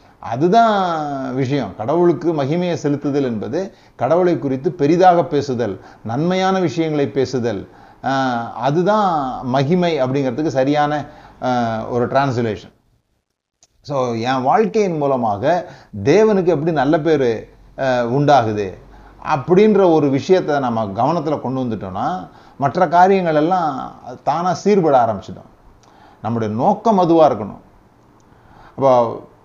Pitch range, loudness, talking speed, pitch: 125-175 Hz, -17 LUFS, 95 wpm, 145 Hz